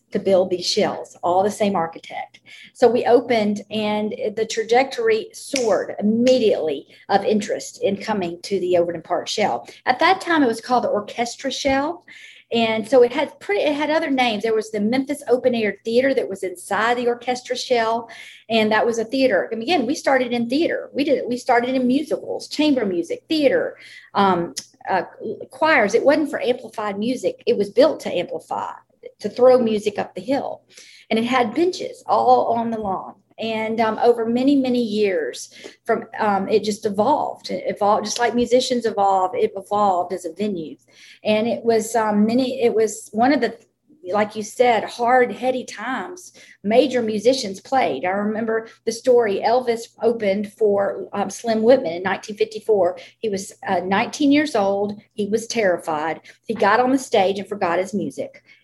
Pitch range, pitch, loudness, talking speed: 210-260 Hz, 230 Hz, -20 LUFS, 180 wpm